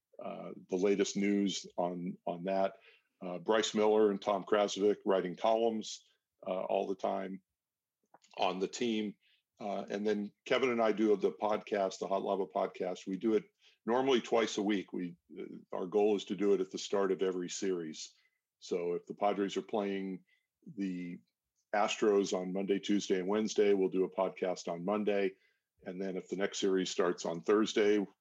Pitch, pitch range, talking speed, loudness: 100 Hz, 95-105 Hz, 180 wpm, -34 LUFS